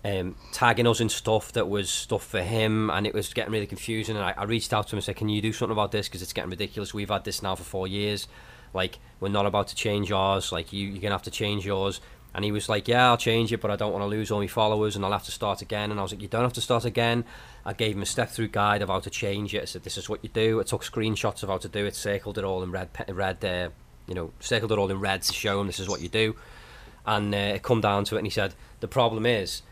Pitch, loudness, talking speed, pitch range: 105 Hz, -27 LUFS, 305 wpm, 100-110 Hz